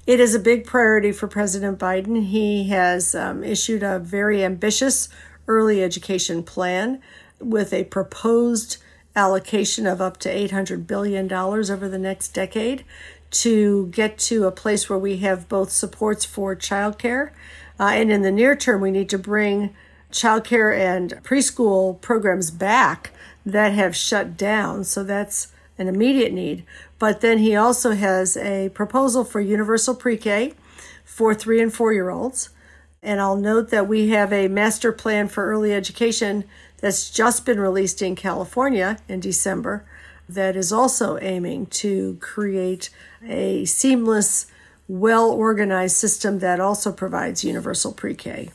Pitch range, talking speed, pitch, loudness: 190-225 Hz, 150 wpm, 205 Hz, -20 LUFS